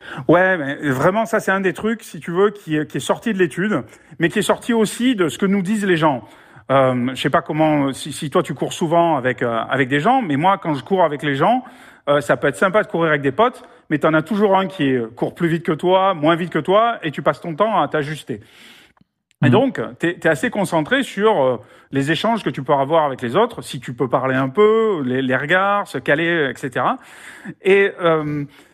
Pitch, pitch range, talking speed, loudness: 165 Hz, 145-200 Hz, 245 wpm, -18 LUFS